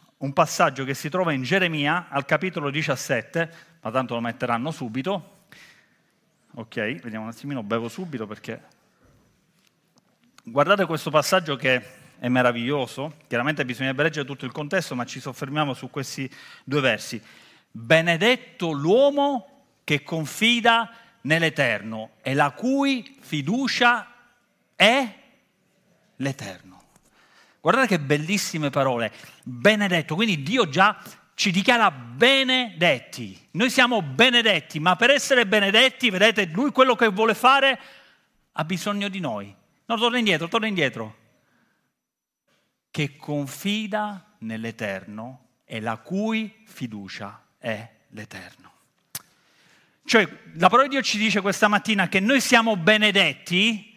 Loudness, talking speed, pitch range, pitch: -22 LUFS, 120 wpm, 135-220 Hz, 175 Hz